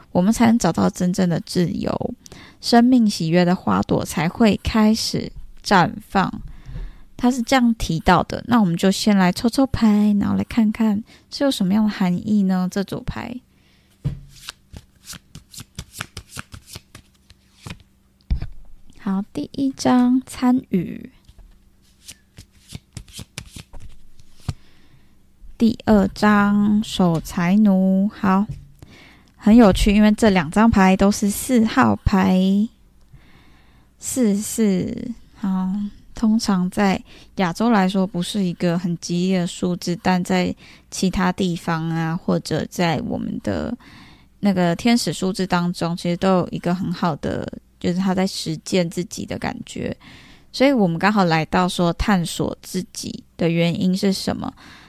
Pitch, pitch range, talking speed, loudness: 190 Hz, 175-215 Hz, 180 characters per minute, -19 LUFS